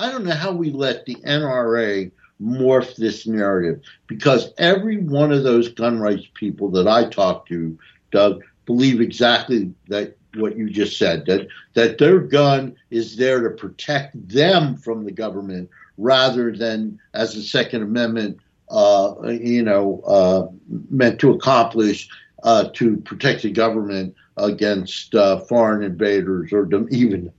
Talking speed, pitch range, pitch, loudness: 145 wpm, 100-125 Hz, 110 Hz, -19 LUFS